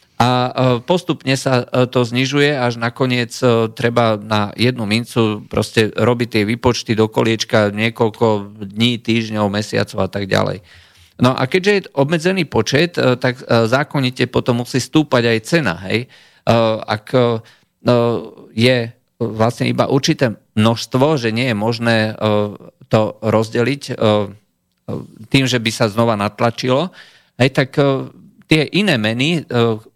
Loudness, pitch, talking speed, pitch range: -16 LUFS, 120 Hz, 120 wpm, 110-130 Hz